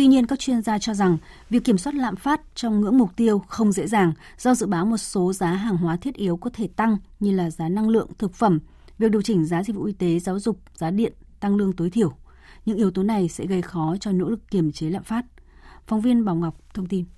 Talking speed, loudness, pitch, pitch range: 260 wpm, -23 LUFS, 205 Hz, 180-225 Hz